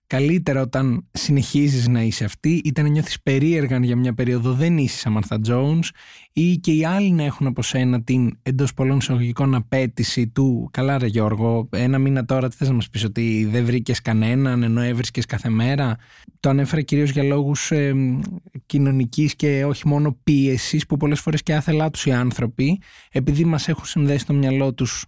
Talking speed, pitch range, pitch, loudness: 185 wpm, 125-150 Hz, 135 Hz, -20 LUFS